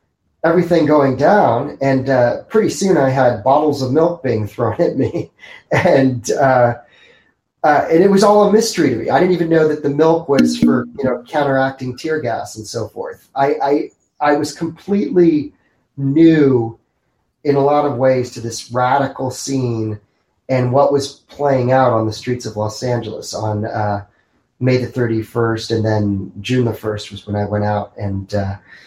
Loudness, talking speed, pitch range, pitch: -16 LUFS, 185 wpm, 110-145 Hz, 125 Hz